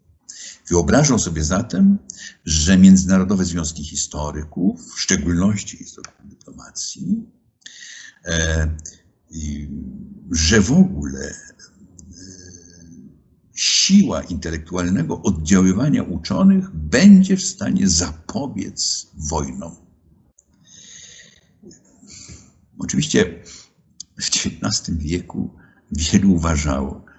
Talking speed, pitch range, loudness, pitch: 65 wpm, 80-100 Hz, -18 LUFS, 90 Hz